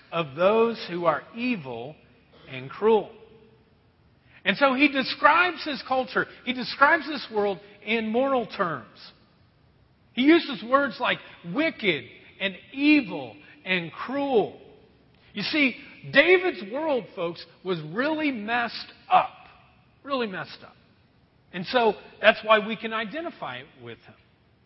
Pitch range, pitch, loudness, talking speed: 170-275 Hz, 220 Hz, -24 LUFS, 125 wpm